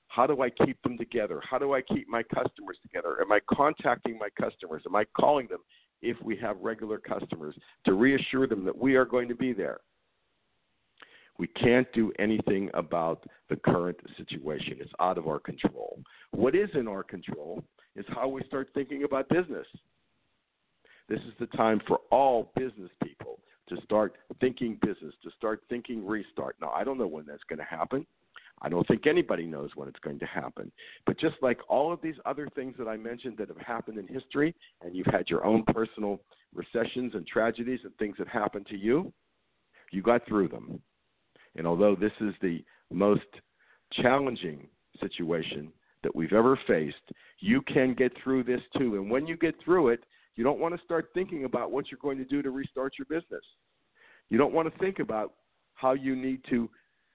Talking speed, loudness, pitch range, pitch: 190 wpm, -30 LUFS, 105-135 Hz, 125 Hz